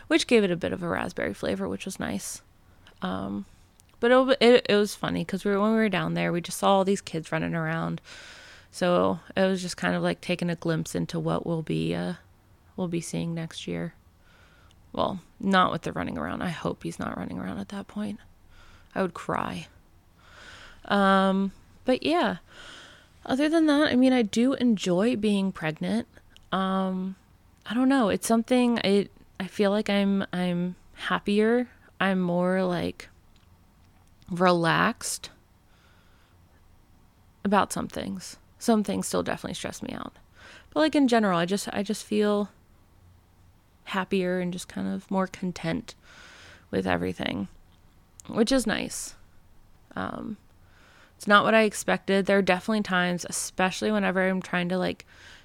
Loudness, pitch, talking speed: -26 LUFS, 180 Hz, 160 wpm